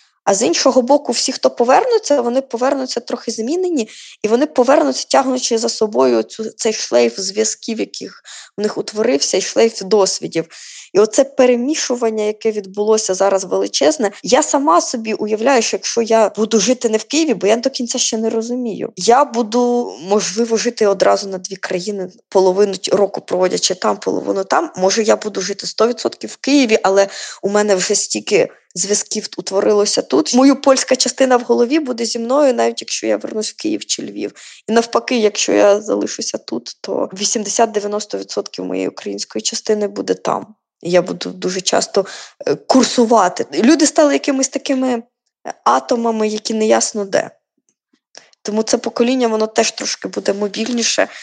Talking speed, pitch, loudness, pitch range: 155 wpm, 225 Hz, -16 LUFS, 200-255 Hz